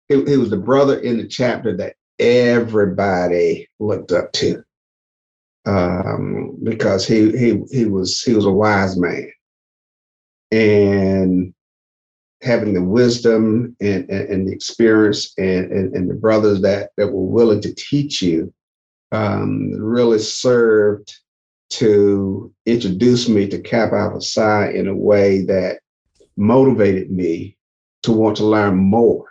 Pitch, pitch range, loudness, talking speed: 105 Hz, 95-115 Hz, -16 LUFS, 135 wpm